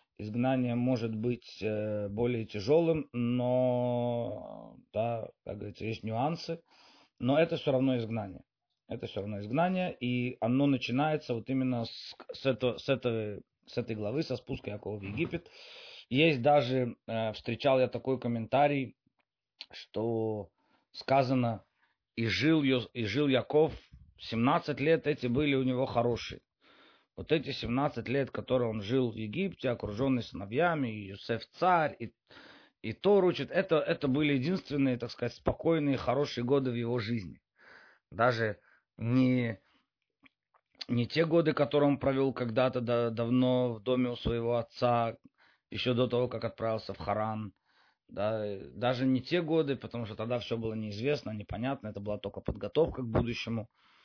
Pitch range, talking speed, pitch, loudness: 115-140 Hz, 140 wpm, 125 Hz, -31 LUFS